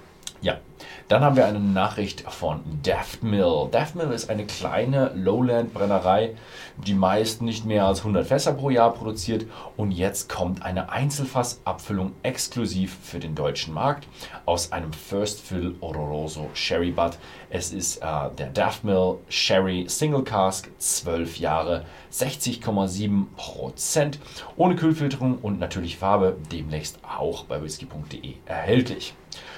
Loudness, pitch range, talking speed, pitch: -25 LUFS, 90-115 Hz, 130 wpm, 100 Hz